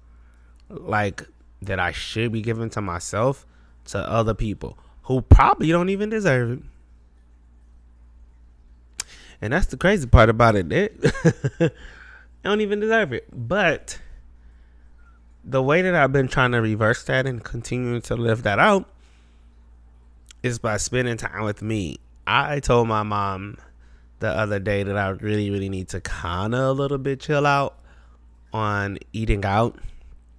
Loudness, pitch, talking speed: -22 LUFS, 105 Hz, 145 wpm